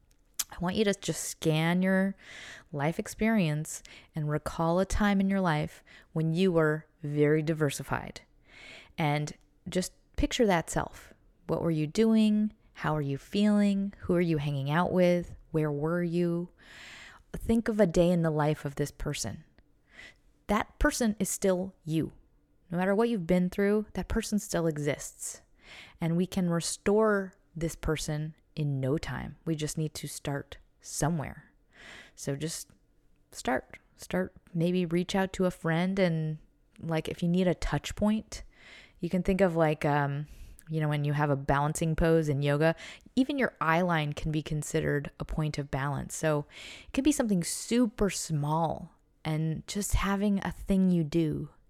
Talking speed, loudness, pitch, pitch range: 165 wpm, -30 LUFS, 165 Hz, 150-190 Hz